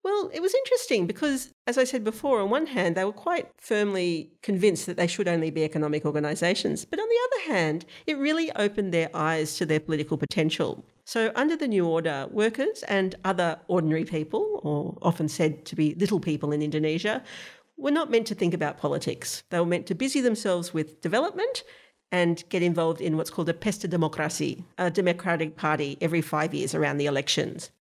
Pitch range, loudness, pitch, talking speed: 155-220 Hz, -27 LUFS, 175 Hz, 195 wpm